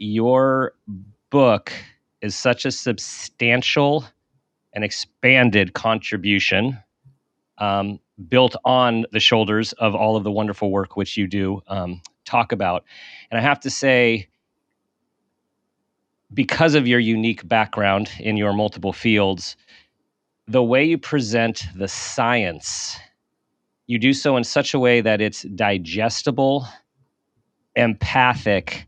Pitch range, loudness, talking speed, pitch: 100-125 Hz, -19 LUFS, 120 wpm, 115 Hz